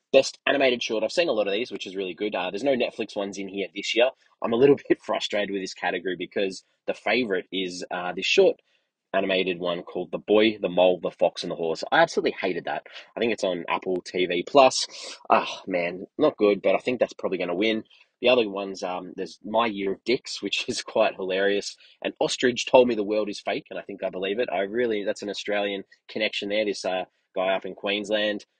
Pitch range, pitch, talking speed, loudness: 95-110 Hz, 100 Hz, 235 wpm, -25 LUFS